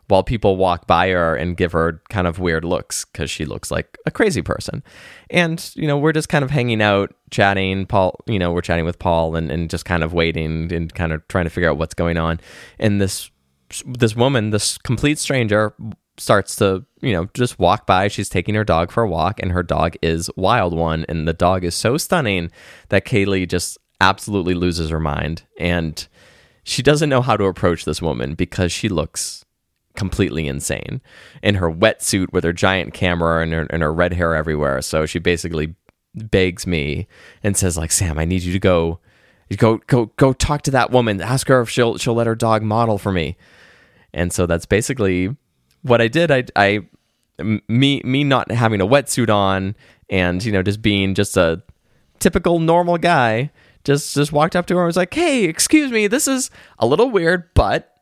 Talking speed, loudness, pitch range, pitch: 205 wpm, -18 LUFS, 85-120 Hz, 95 Hz